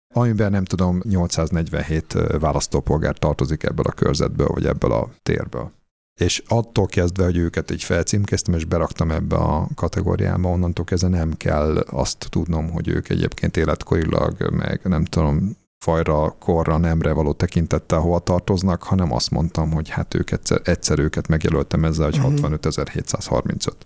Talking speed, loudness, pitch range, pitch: 145 wpm, -21 LUFS, 80-95 Hz, 85 Hz